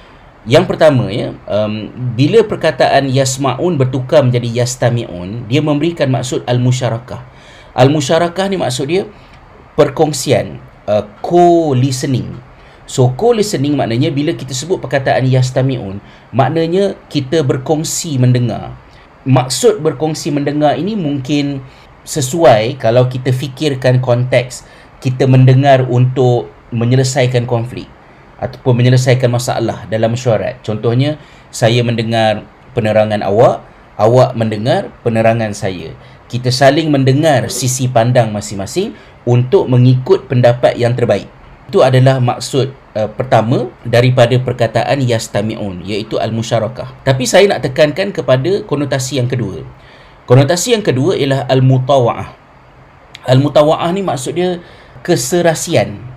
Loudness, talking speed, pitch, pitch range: -13 LUFS, 110 wpm, 130 Hz, 120-145 Hz